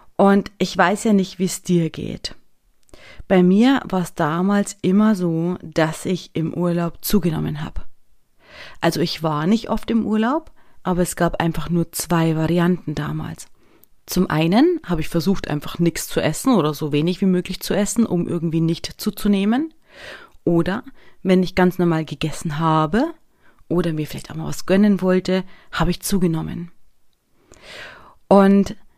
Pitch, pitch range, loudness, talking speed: 180 Hz, 165-200 Hz, -20 LUFS, 155 wpm